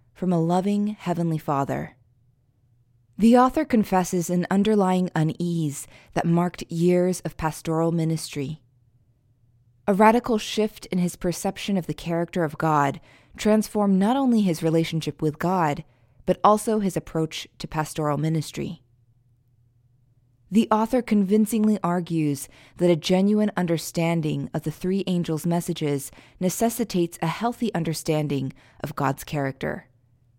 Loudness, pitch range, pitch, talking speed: -24 LUFS, 140-185 Hz, 165 Hz, 120 wpm